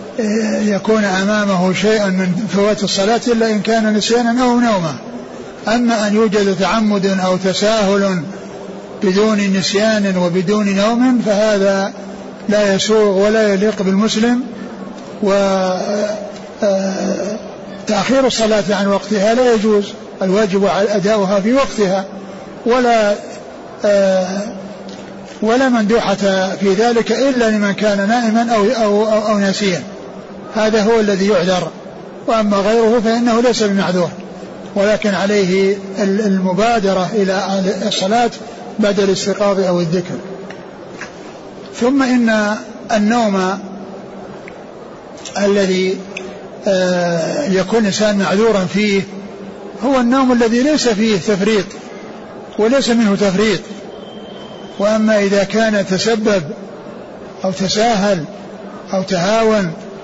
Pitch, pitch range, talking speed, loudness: 205 Hz, 195-220 Hz, 95 wpm, -15 LUFS